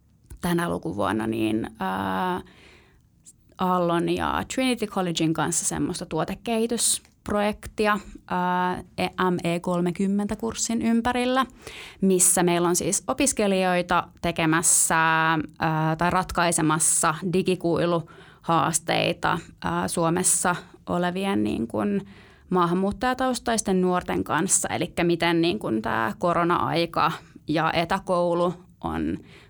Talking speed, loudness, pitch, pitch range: 75 wpm, -24 LUFS, 175 Hz, 165-195 Hz